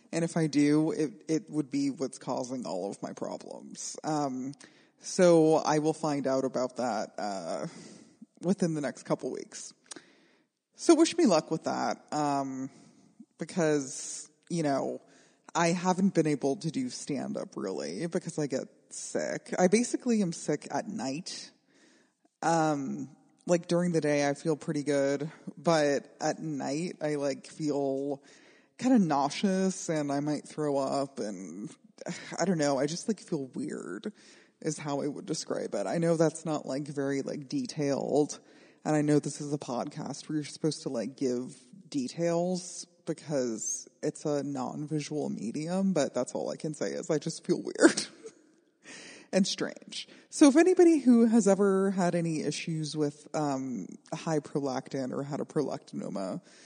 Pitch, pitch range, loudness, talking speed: 155 Hz, 145-190 Hz, -30 LUFS, 160 wpm